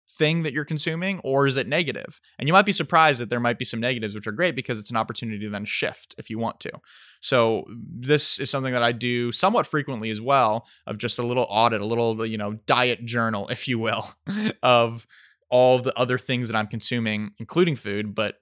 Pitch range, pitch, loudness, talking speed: 110-140 Hz, 120 Hz, -23 LUFS, 225 wpm